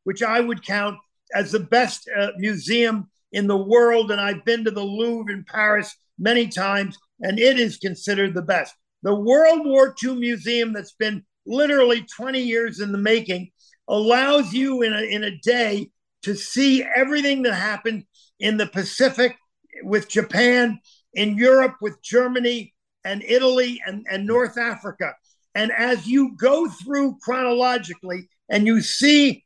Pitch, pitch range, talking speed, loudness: 225 Hz, 205-245 Hz, 155 wpm, -20 LUFS